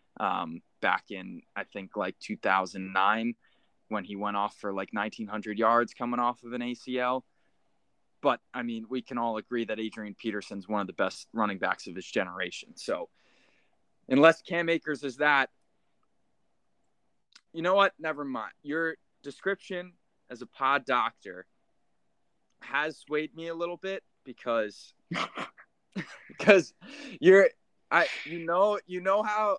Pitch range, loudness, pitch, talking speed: 110-170 Hz, -29 LUFS, 125 Hz, 145 wpm